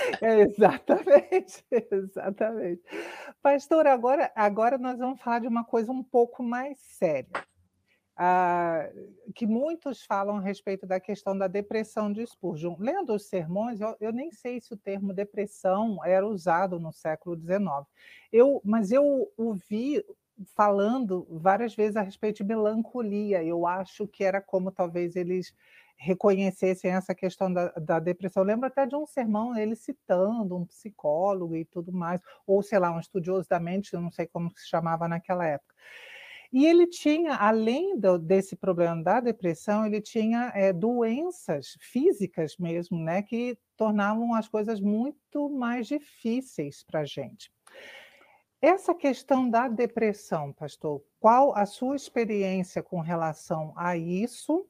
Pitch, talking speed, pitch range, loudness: 205 Hz, 145 wpm, 180-240 Hz, -27 LUFS